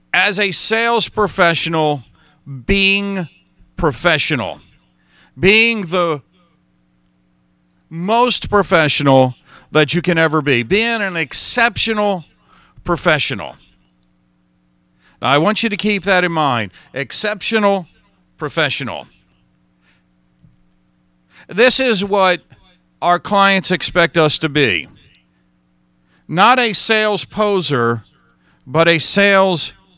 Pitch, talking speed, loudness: 160 Hz, 90 wpm, -13 LUFS